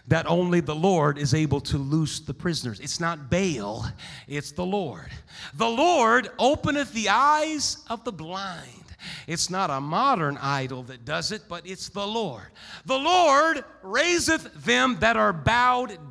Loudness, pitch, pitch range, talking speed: -24 LUFS, 180 Hz, 145-230 Hz, 165 wpm